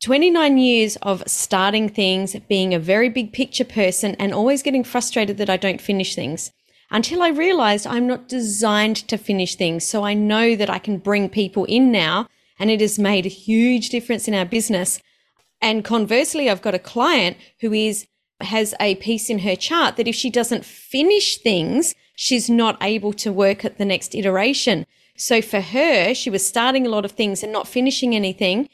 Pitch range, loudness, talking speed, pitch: 200-245 Hz, -19 LUFS, 190 wpm, 215 Hz